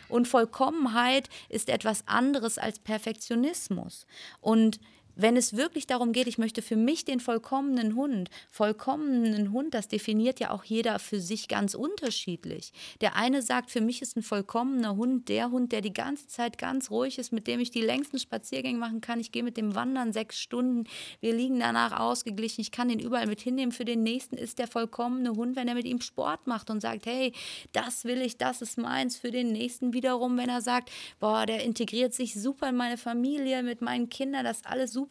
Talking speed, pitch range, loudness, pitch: 200 wpm, 225-255 Hz, -30 LUFS, 240 Hz